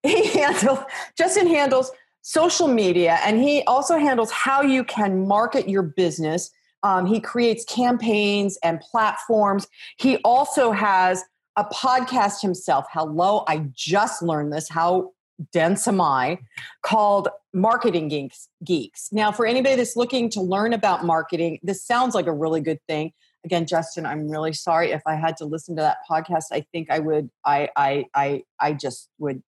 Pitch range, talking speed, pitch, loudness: 160-235 Hz, 160 wpm, 190 Hz, -21 LUFS